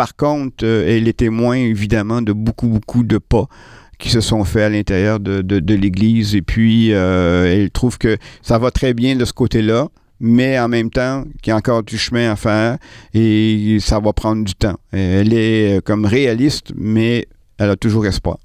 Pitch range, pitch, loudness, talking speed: 105-120 Hz, 110 Hz, -16 LUFS, 200 wpm